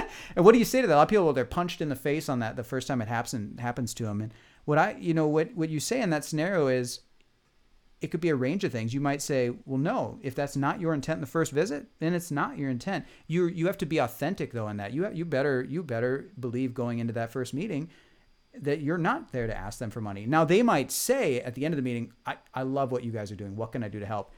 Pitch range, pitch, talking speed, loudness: 120-160 Hz, 135 Hz, 295 wpm, -28 LUFS